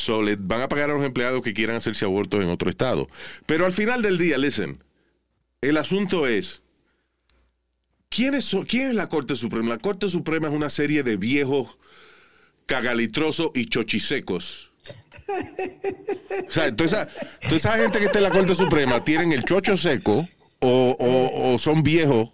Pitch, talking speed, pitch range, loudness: 150 Hz, 165 wpm, 115-195 Hz, -22 LUFS